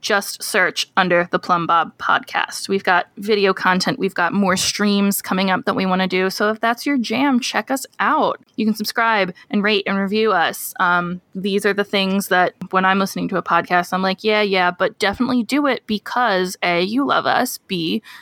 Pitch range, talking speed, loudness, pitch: 185-215 Hz, 210 wpm, -18 LUFS, 195 Hz